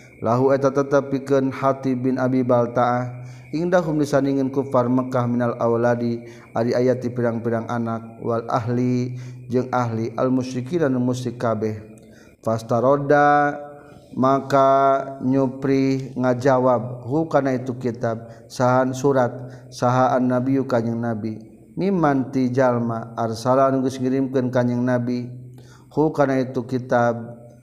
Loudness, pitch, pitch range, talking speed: -21 LUFS, 125 Hz, 120-135 Hz, 110 wpm